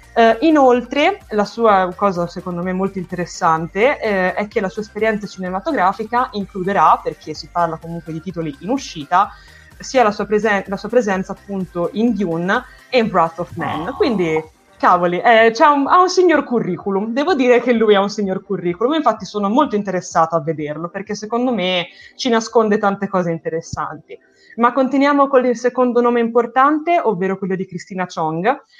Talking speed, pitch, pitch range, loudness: 175 wpm, 205 Hz, 180-245 Hz, -17 LUFS